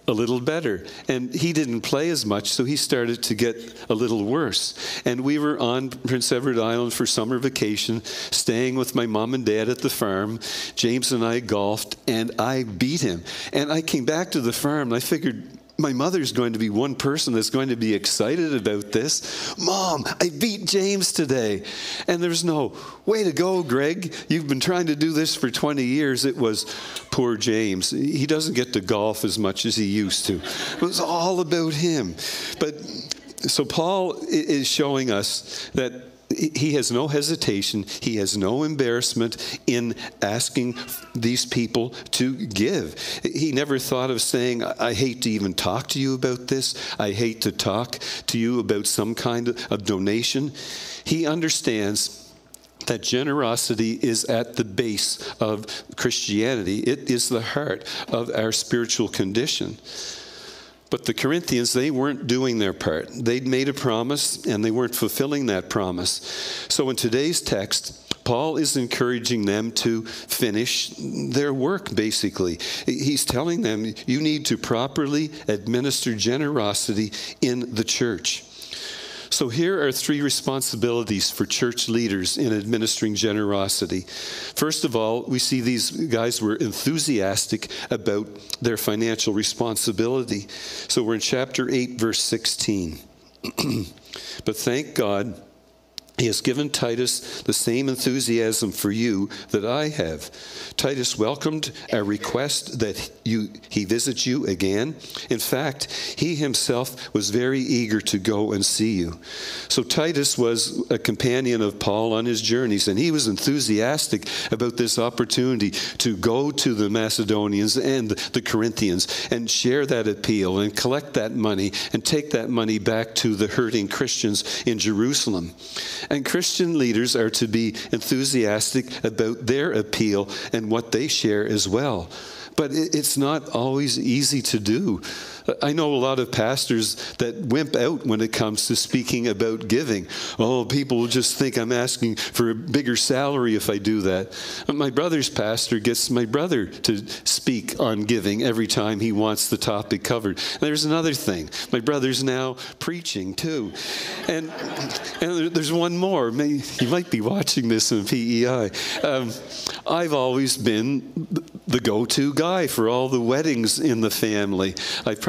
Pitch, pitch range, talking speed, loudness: 120 Hz, 110-135 Hz, 160 wpm, -23 LUFS